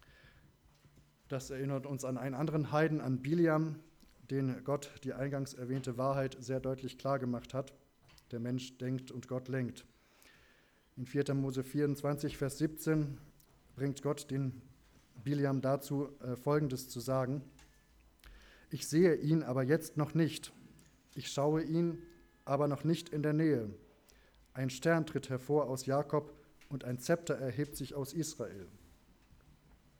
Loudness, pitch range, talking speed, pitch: -36 LUFS, 130-150 Hz, 140 wpm, 140 Hz